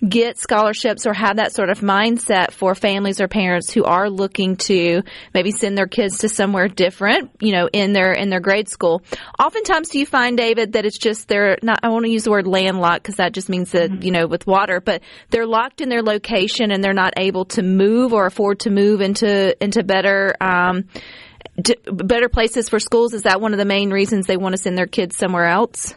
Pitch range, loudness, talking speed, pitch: 190-225 Hz, -17 LUFS, 220 wpm, 200 Hz